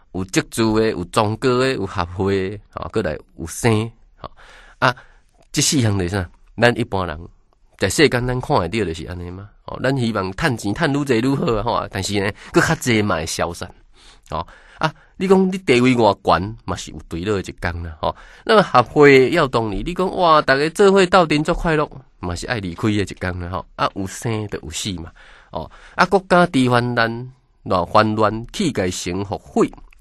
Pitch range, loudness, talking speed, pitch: 95-140 Hz, -19 LUFS, 275 characters per minute, 110 Hz